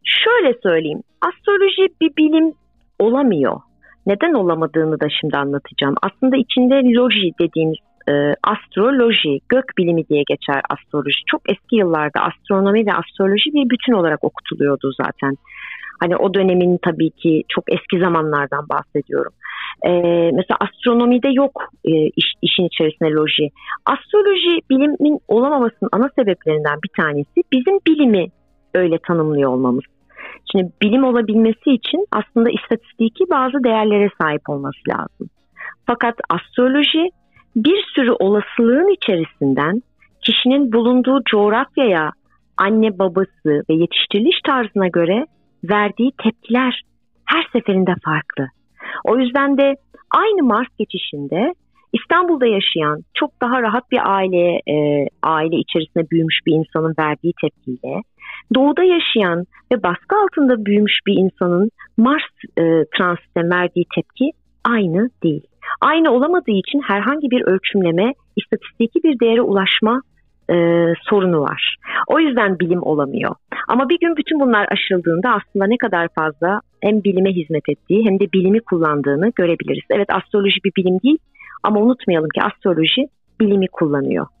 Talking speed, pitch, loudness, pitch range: 125 wpm, 200 Hz, -17 LUFS, 170-255 Hz